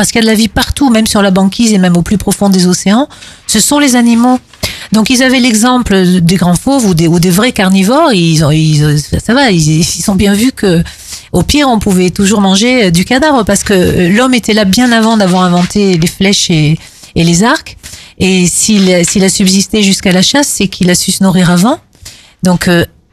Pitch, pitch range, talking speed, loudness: 195 Hz, 180-230 Hz, 225 wpm, -8 LUFS